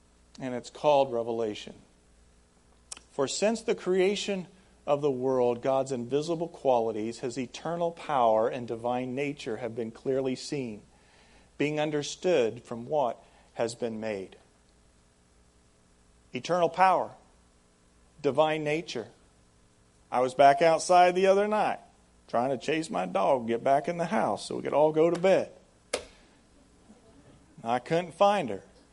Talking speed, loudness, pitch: 135 wpm, -28 LUFS, 125 Hz